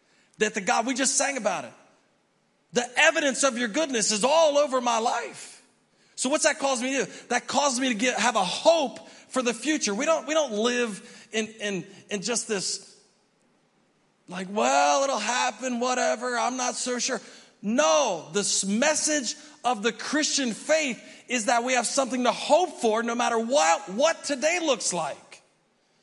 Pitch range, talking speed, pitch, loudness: 220-280 Hz, 180 wpm, 245 Hz, -25 LUFS